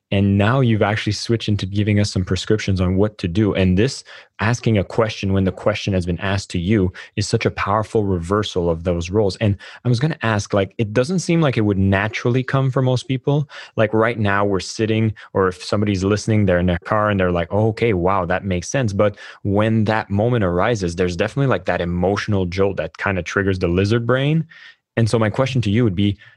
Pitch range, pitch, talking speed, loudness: 95-115 Hz, 105 Hz, 230 wpm, -19 LUFS